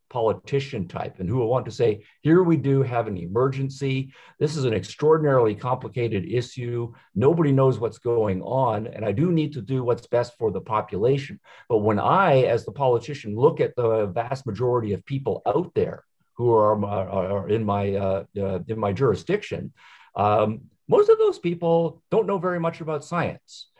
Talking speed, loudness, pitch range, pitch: 185 wpm, -23 LUFS, 105-150 Hz, 125 Hz